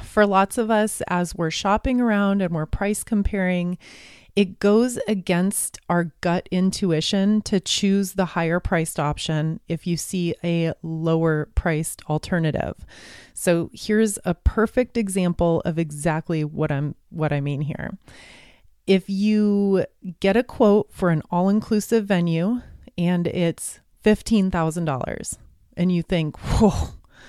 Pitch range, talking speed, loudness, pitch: 165-205 Hz, 140 wpm, -22 LUFS, 180 Hz